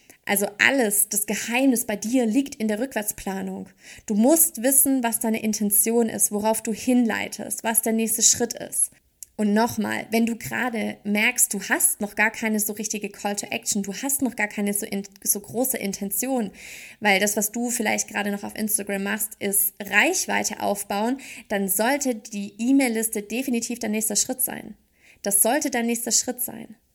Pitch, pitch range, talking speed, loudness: 220 Hz, 205-240 Hz, 175 wpm, -22 LUFS